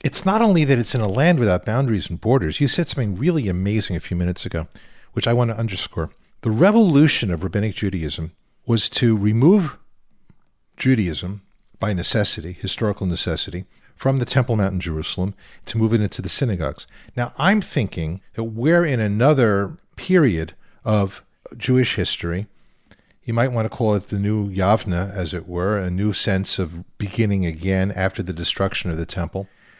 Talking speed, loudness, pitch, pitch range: 175 wpm, -20 LUFS, 105 Hz, 90-120 Hz